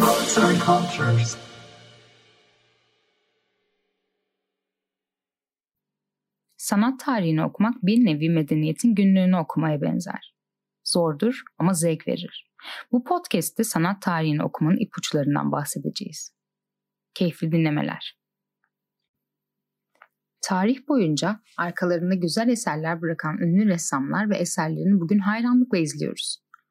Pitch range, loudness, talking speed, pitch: 160-220 Hz, -23 LUFS, 80 wpm, 180 Hz